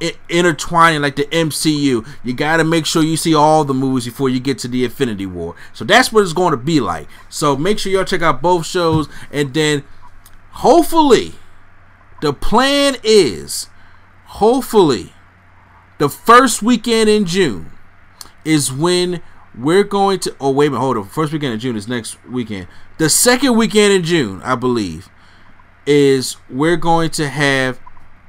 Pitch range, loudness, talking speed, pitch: 120-180 Hz, -15 LUFS, 165 wpm, 150 Hz